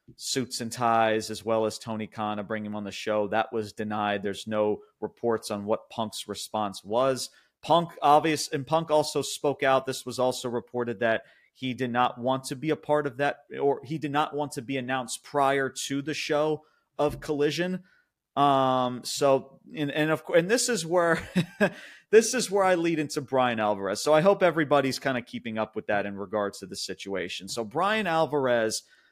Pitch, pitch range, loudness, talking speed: 130 Hz, 110-150 Hz, -27 LUFS, 200 wpm